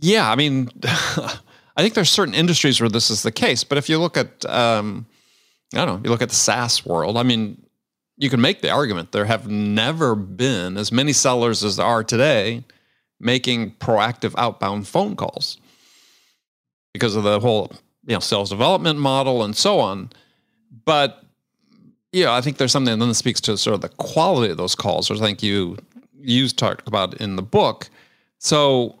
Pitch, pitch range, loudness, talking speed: 120 Hz, 110-135 Hz, -19 LUFS, 190 wpm